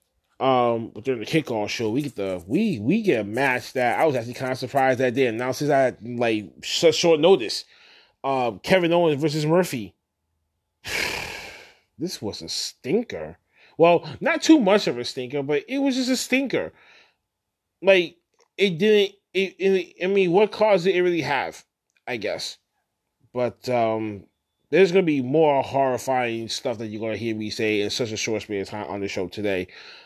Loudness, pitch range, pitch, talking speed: -23 LUFS, 115-190 Hz, 135 Hz, 190 wpm